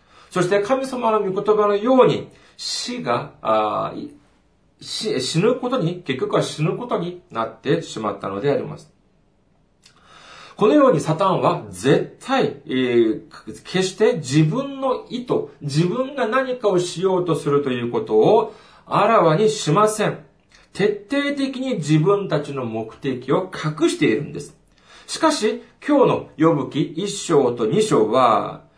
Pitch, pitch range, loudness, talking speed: 185 Hz, 145-245 Hz, -20 LUFS, 260 characters per minute